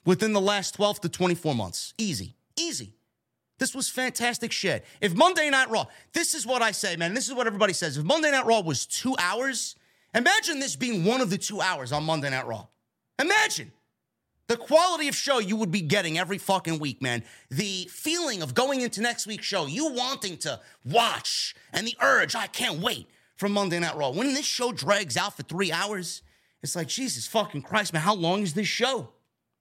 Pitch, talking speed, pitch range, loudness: 205 Hz, 205 wpm, 170-255 Hz, -26 LUFS